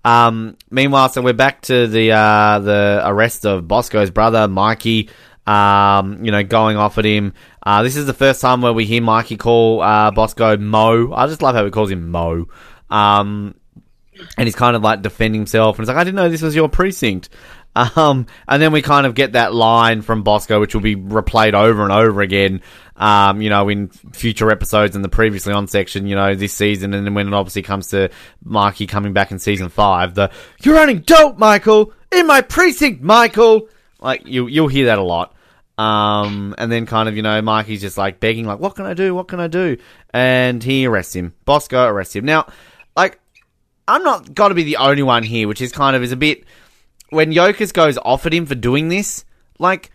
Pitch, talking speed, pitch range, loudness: 110 Hz, 215 wpm, 105-135 Hz, -14 LUFS